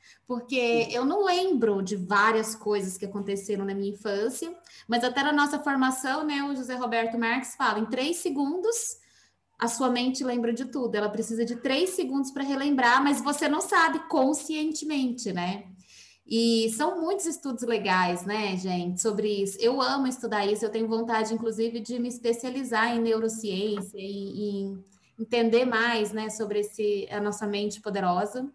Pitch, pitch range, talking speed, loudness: 230 Hz, 210-275 Hz, 165 wpm, -27 LUFS